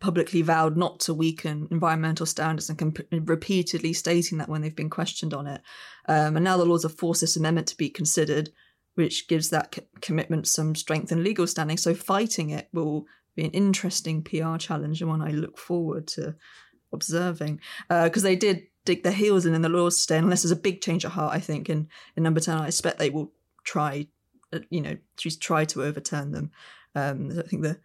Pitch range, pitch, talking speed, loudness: 155-175 Hz, 165 Hz, 210 wpm, -26 LUFS